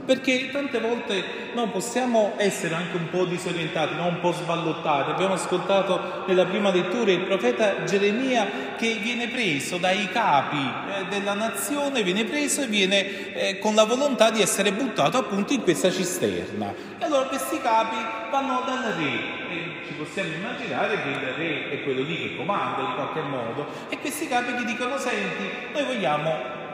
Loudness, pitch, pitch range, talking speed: -24 LUFS, 200 Hz, 180-245 Hz, 170 wpm